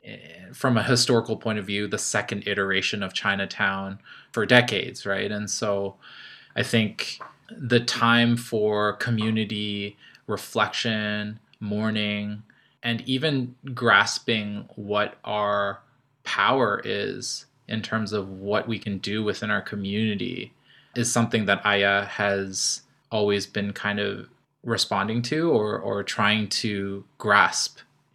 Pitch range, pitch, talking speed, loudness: 100-115 Hz, 105 Hz, 120 wpm, -24 LUFS